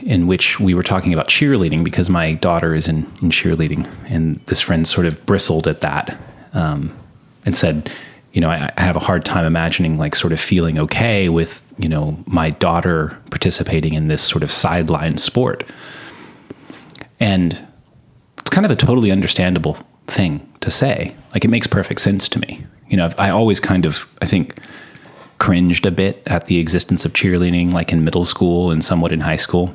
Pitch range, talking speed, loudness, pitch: 80-95 Hz, 190 wpm, -16 LUFS, 85 Hz